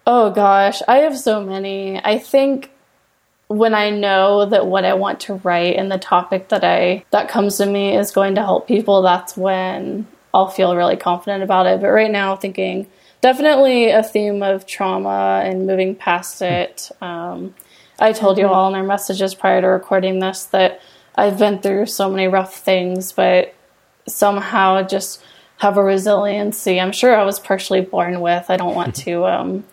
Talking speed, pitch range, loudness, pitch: 180 wpm, 185-205 Hz, -16 LUFS, 195 Hz